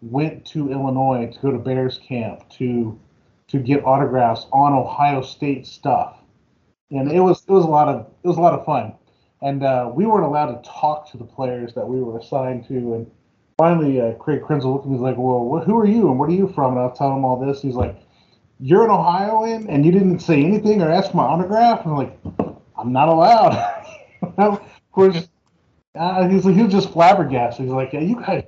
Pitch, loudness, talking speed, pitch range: 140 Hz, -18 LUFS, 220 wpm, 130-175 Hz